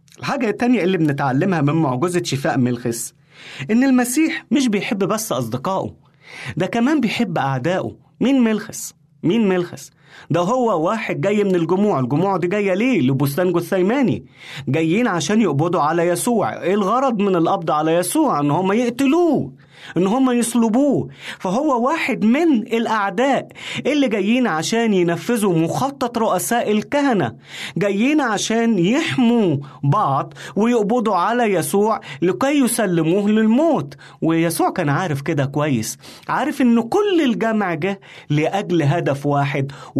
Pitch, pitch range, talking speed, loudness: 195 Hz, 165-240 Hz, 130 wpm, -18 LUFS